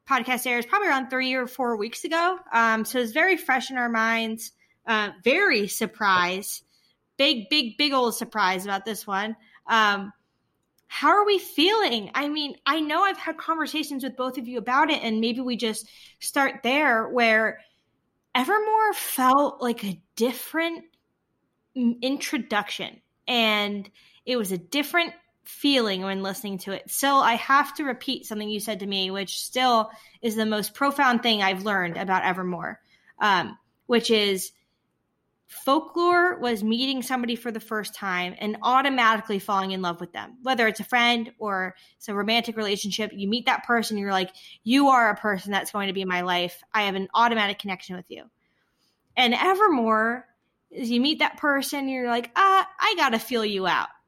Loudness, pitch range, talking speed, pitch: -24 LUFS, 205-270 Hz, 170 wpm, 235 Hz